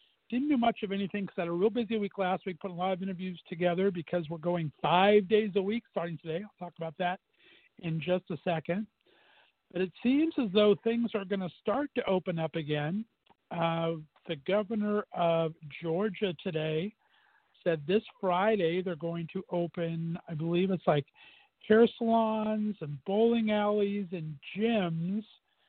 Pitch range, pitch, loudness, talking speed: 170-215 Hz, 190 Hz, -31 LUFS, 175 wpm